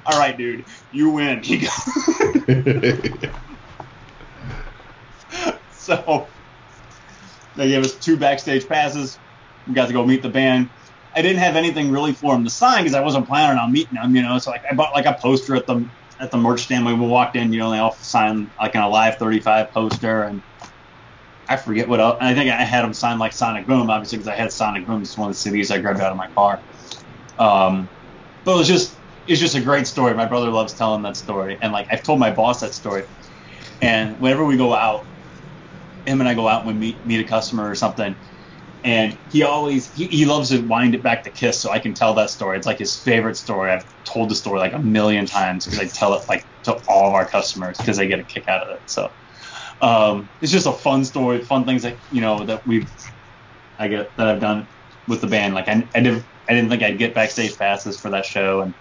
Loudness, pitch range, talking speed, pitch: -19 LUFS, 110-135 Hz, 230 wpm, 120 Hz